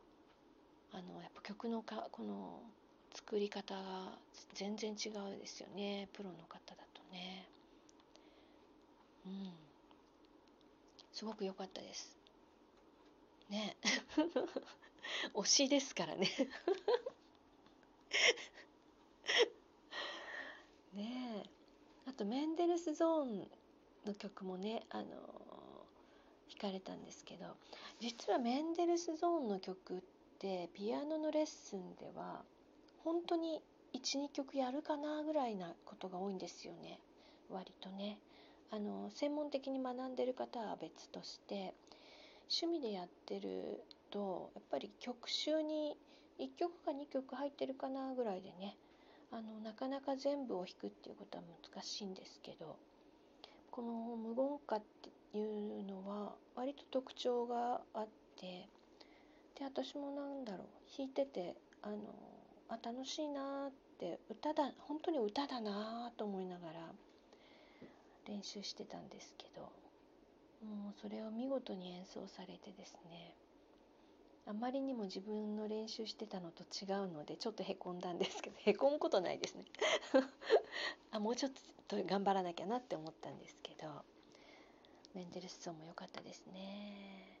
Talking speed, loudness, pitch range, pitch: 240 characters per minute, -43 LUFS, 200-290 Hz, 230 Hz